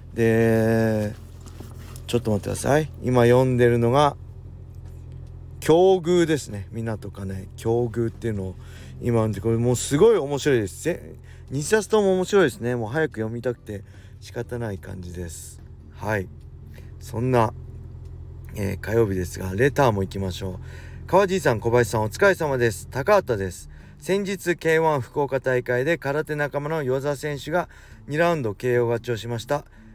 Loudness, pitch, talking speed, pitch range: -23 LUFS, 115 Hz, 305 characters per minute, 100-140 Hz